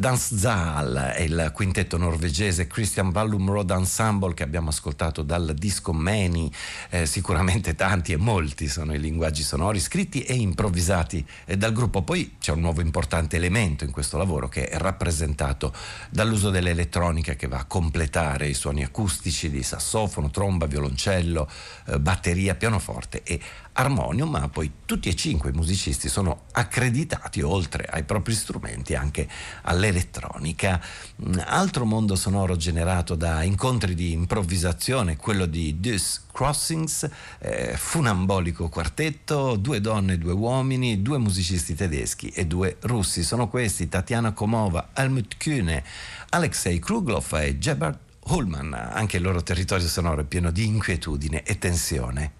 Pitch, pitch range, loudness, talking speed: 90 Hz, 80-105 Hz, -25 LUFS, 140 wpm